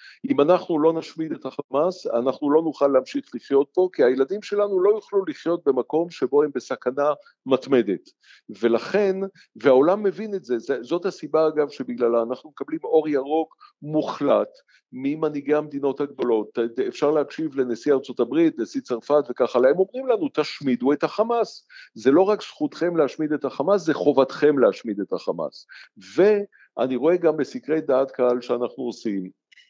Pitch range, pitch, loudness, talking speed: 135-195 Hz, 155 Hz, -23 LUFS, 150 wpm